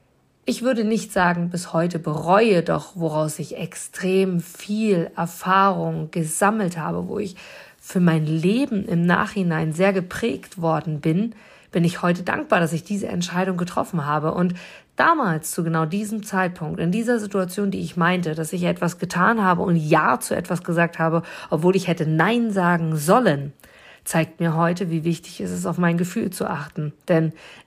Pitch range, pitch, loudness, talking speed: 165-195 Hz, 175 Hz, -22 LUFS, 170 wpm